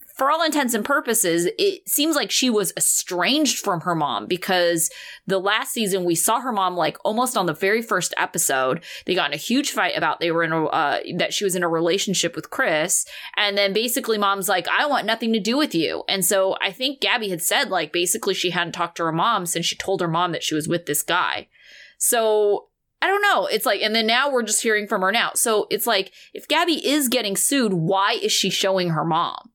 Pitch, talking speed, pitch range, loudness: 200 Hz, 235 wpm, 175-245 Hz, -21 LUFS